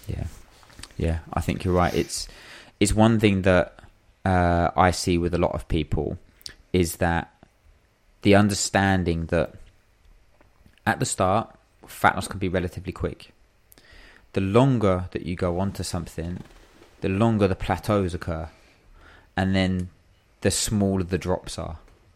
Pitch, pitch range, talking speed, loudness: 95 Hz, 85-100 Hz, 145 wpm, -24 LUFS